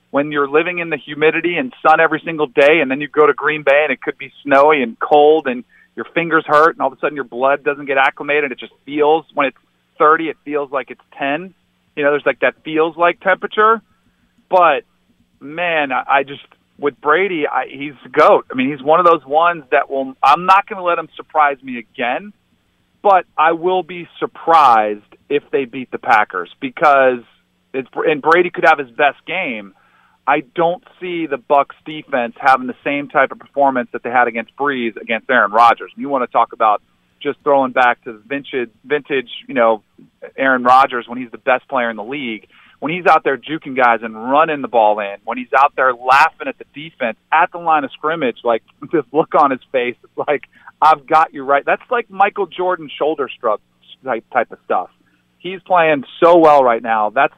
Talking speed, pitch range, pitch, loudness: 210 wpm, 125-160 Hz, 145 Hz, -15 LUFS